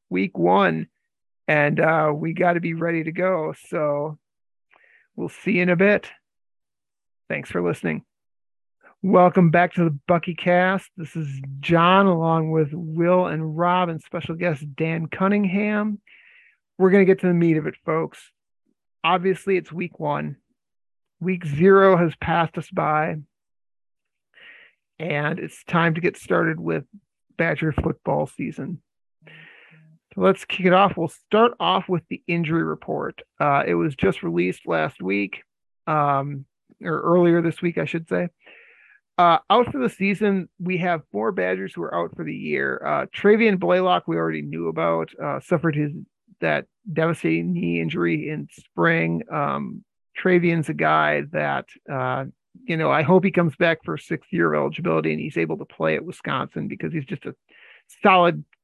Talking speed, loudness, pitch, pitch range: 160 wpm, -22 LUFS, 170 Hz, 150-185 Hz